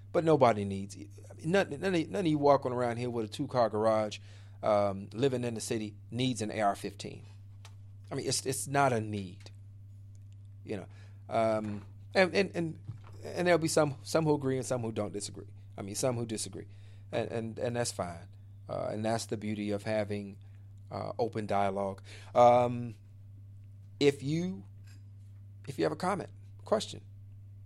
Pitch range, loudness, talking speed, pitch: 100-120 Hz, -32 LUFS, 170 wpm, 105 Hz